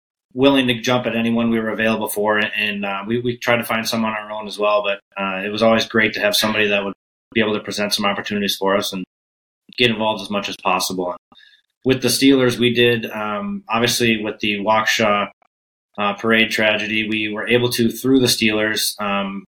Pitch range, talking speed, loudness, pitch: 100-115 Hz, 215 wpm, -18 LUFS, 110 Hz